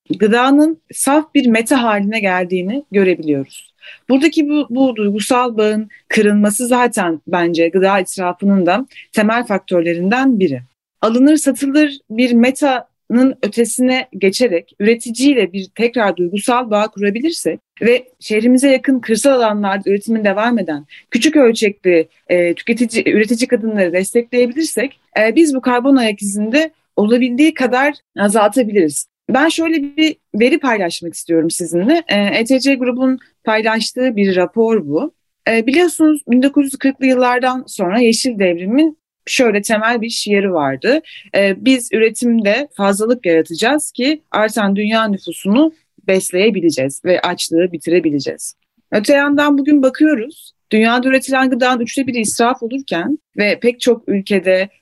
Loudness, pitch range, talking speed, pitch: -14 LUFS, 200-265 Hz, 120 wpm, 230 Hz